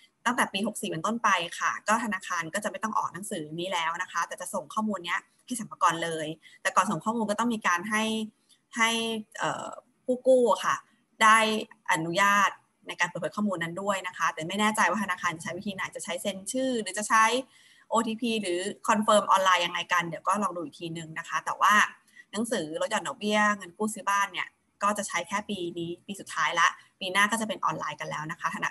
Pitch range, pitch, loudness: 180-220 Hz, 205 Hz, -27 LUFS